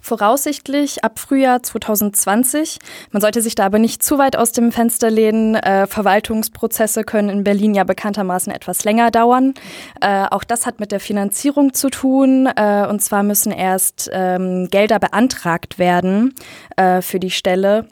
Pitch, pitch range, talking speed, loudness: 215 Hz, 195-235 Hz, 160 wpm, -16 LUFS